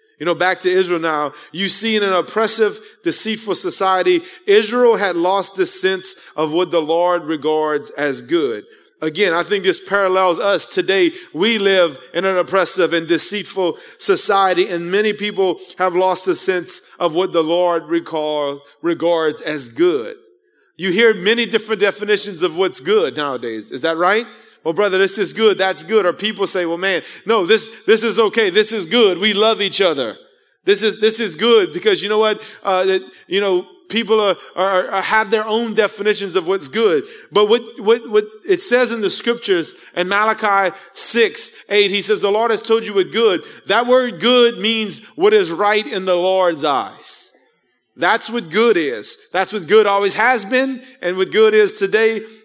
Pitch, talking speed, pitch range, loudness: 205 Hz, 185 wpm, 185-230 Hz, -16 LUFS